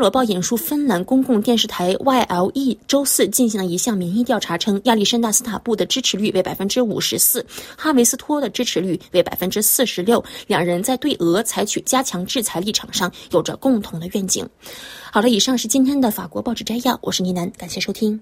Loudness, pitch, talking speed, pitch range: -18 LUFS, 220 Hz, 335 characters per minute, 185-255 Hz